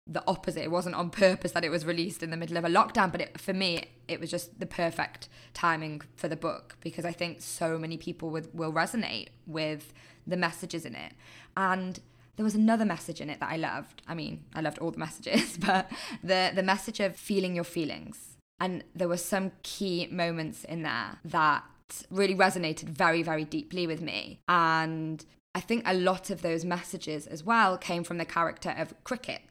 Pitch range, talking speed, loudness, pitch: 165-185 Hz, 205 wpm, -30 LUFS, 175 Hz